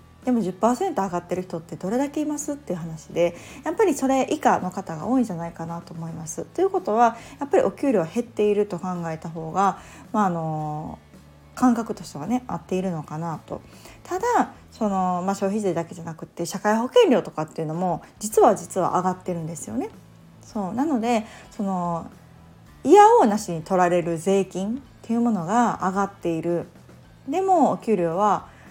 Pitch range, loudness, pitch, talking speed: 170-240 Hz, -23 LUFS, 195 Hz, 360 characters per minute